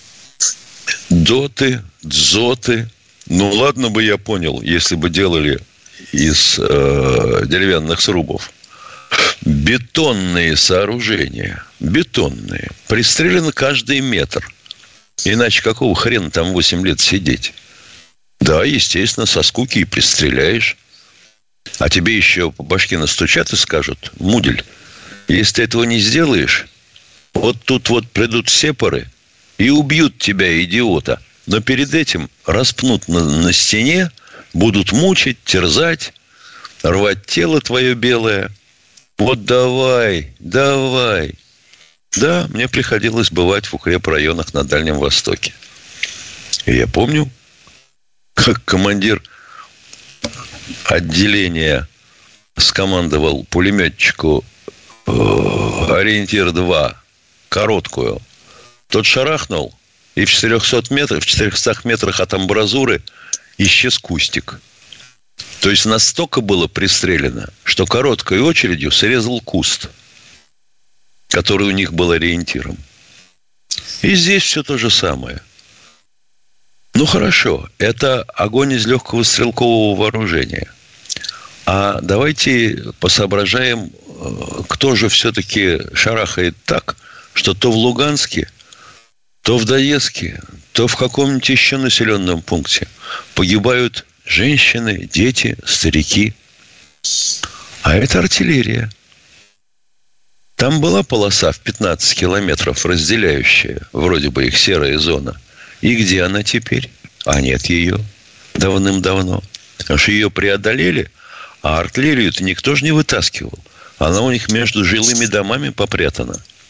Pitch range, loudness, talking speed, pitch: 90-125 Hz, -14 LUFS, 100 wpm, 105 Hz